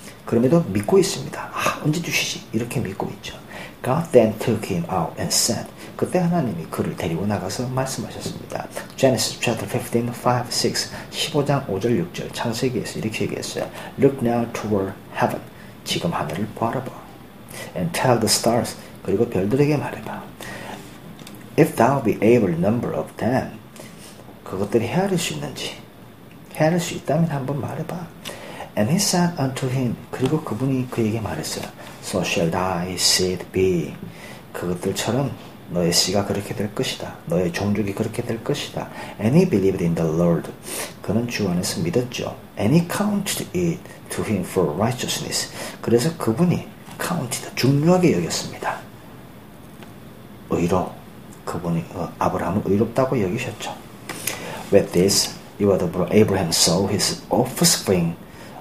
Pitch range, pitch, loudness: 105-170 Hz, 130 Hz, -22 LUFS